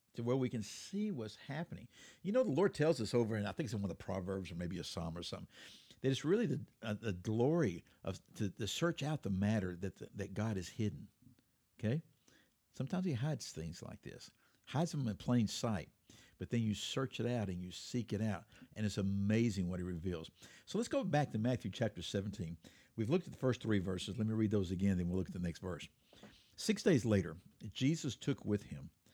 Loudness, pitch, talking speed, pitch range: -39 LUFS, 110 Hz, 230 wpm, 95-130 Hz